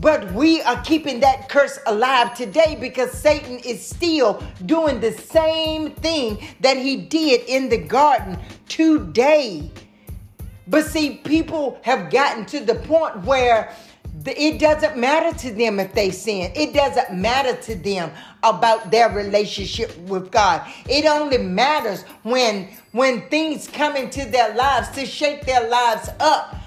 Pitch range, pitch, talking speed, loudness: 225-300 Hz, 260 Hz, 145 wpm, -19 LUFS